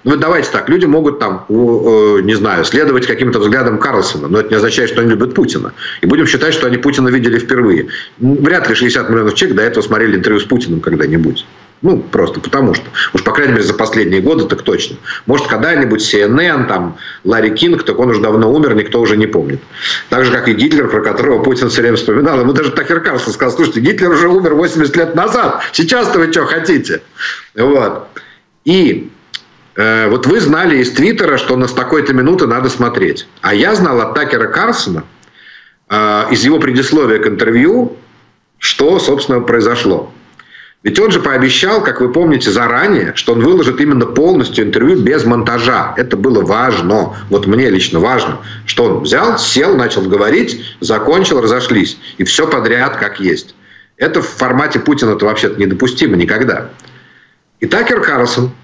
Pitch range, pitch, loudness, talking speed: 110-130 Hz, 120 Hz, -11 LUFS, 175 wpm